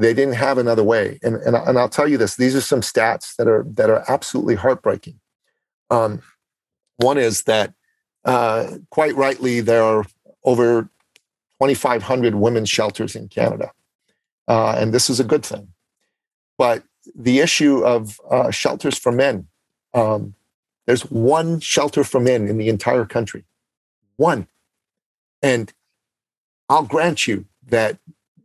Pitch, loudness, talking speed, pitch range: 125 Hz, -18 LUFS, 145 wpm, 110-140 Hz